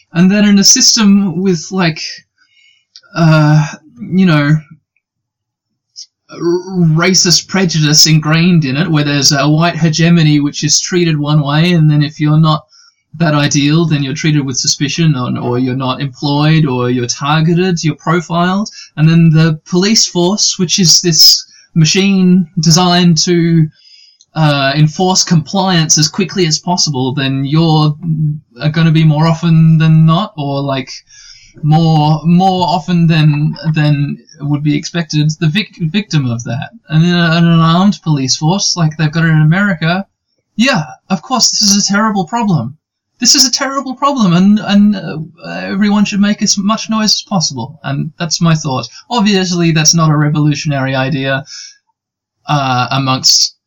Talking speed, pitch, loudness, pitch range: 155 wpm, 160 Hz, -11 LUFS, 150-185 Hz